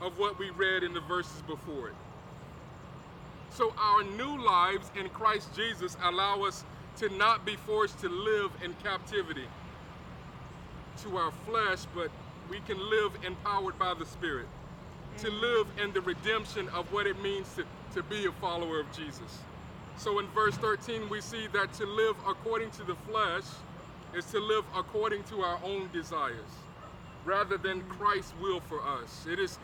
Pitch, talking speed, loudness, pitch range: 200 Hz, 165 wpm, -32 LUFS, 180-215 Hz